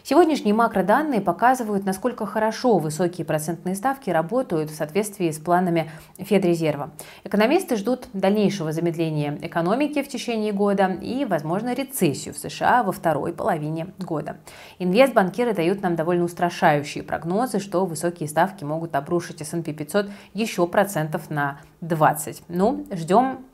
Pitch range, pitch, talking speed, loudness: 165-215 Hz, 185 Hz, 125 wpm, -23 LUFS